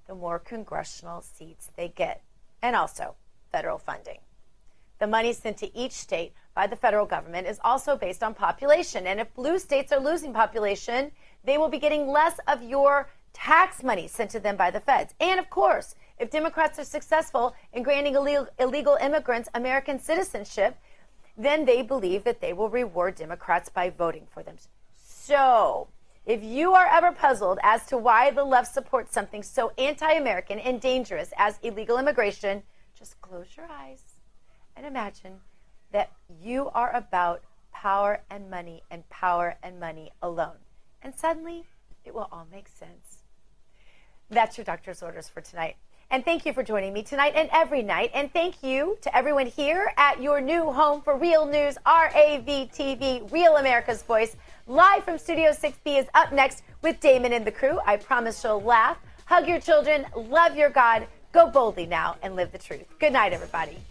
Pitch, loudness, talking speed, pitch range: 260 Hz, -24 LUFS, 170 wpm, 205-300 Hz